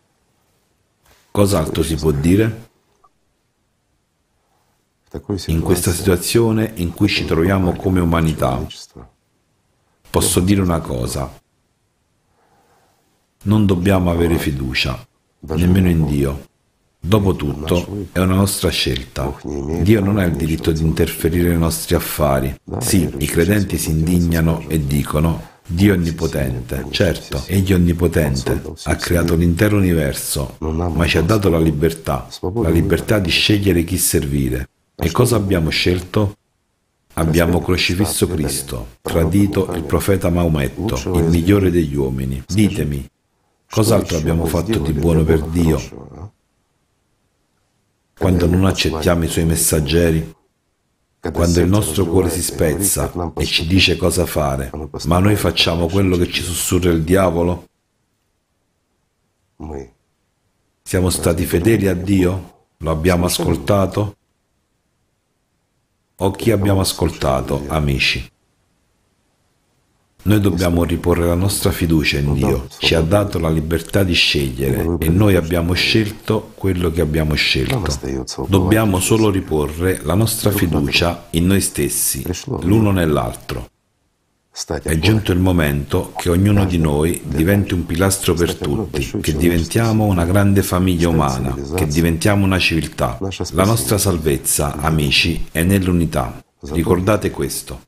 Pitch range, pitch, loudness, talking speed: 80-95 Hz, 85 Hz, -17 LUFS, 120 wpm